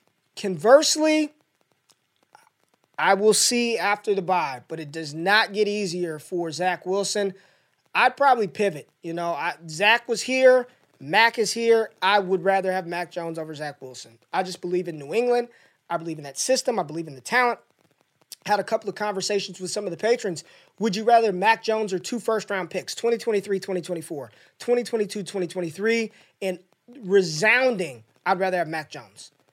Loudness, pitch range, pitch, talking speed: -23 LUFS, 175-225 Hz, 195 Hz, 170 wpm